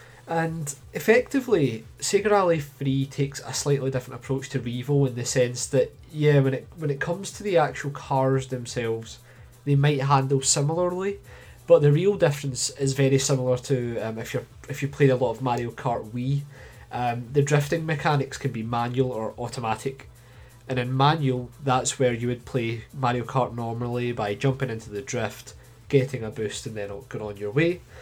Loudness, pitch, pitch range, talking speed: -25 LUFS, 130 Hz, 120-140 Hz, 180 wpm